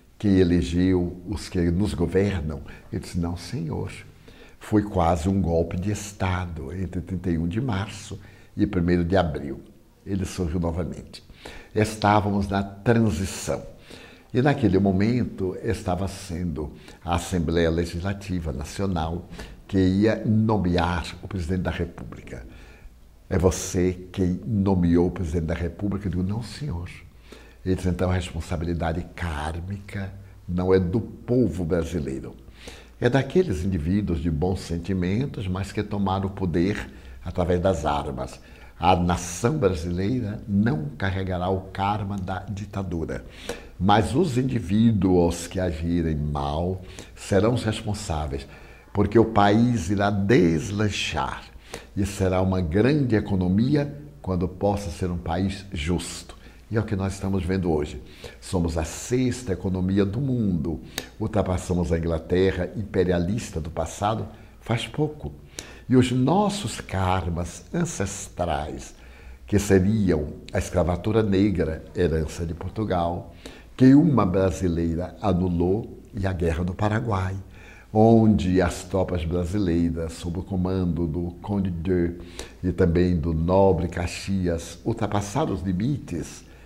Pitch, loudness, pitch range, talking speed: 95 Hz, -25 LUFS, 85-100 Hz, 125 wpm